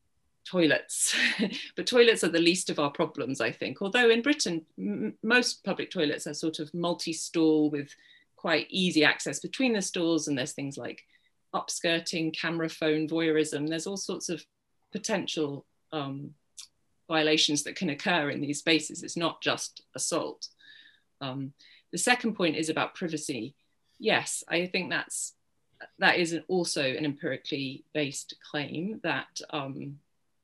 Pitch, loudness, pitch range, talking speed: 160 Hz, -28 LUFS, 150-180 Hz, 150 wpm